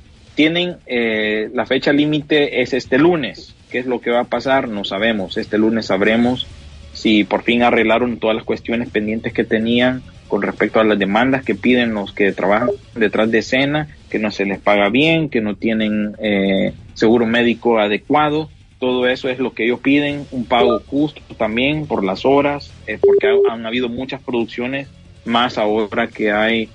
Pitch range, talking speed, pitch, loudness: 105-130 Hz, 180 wpm, 115 Hz, -17 LUFS